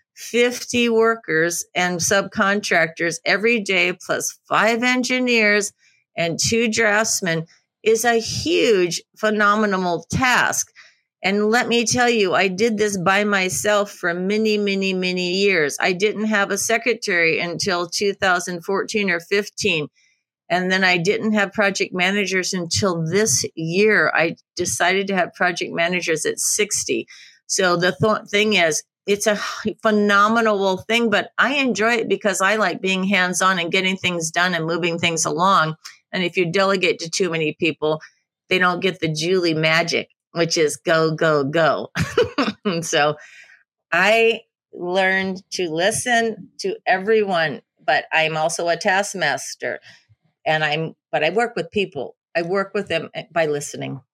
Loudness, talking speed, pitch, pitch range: -19 LUFS, 145 wpm, 190 Hz, 170-215 Hz